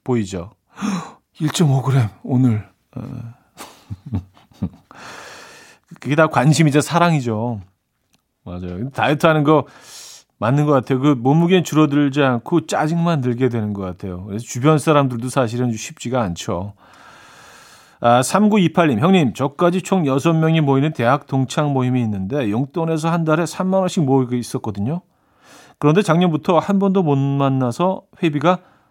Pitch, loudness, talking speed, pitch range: 140 Hz, -18 LUFS, 270 characters per minute, 120-165 Hz